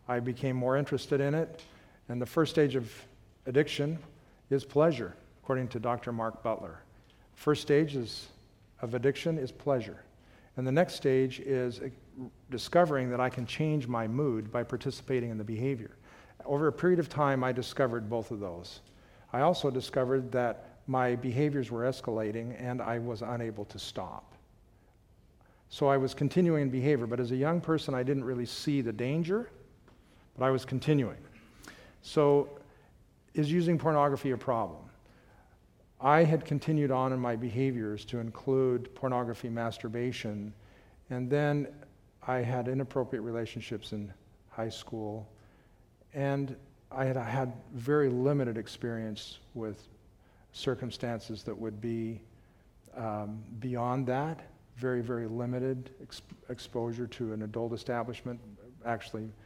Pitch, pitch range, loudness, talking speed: 125 Hz, 115-135 Hz, -32 LUFS, 140 wpm